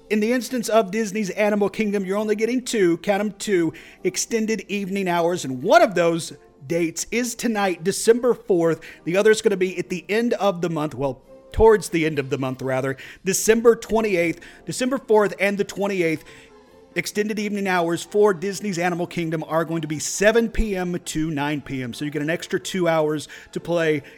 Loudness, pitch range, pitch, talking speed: -22 LUFS, 160-210 Hz, 185 Hz, 195 wpm